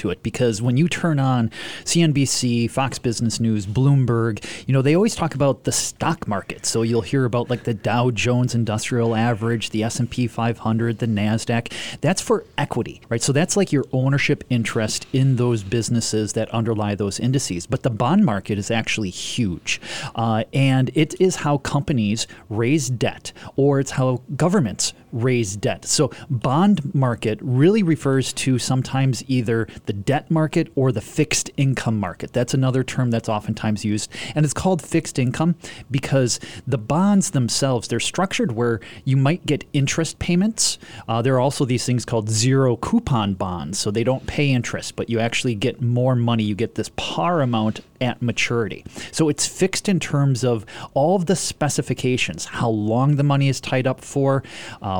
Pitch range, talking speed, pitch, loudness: 115-140 Hz, 175 wpm, 125 Hz, -21 LUFS